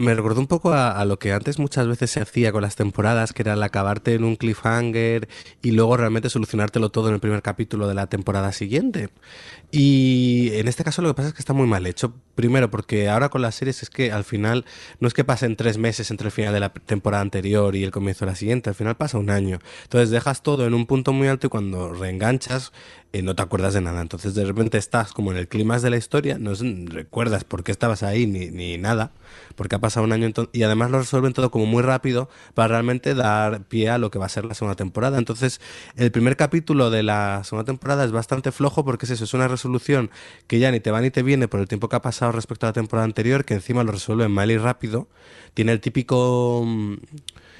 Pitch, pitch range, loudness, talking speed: 115 Hz, 105-125 Hz, -22 LUFS, 245 wpm